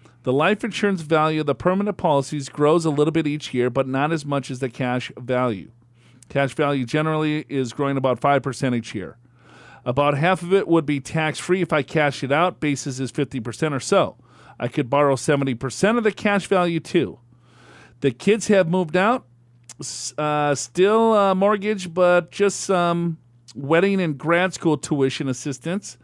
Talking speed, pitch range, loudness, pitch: 175 wpm, 130-175 Hz, -21 LUFS, 150 Hz